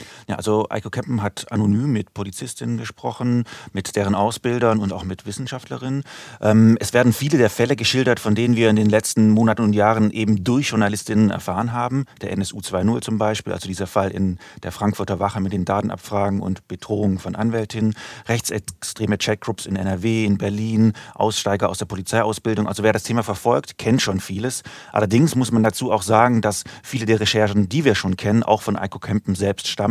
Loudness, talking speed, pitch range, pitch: -20 LUFS, 185 wpm, 100-115 Hz, 110 Hz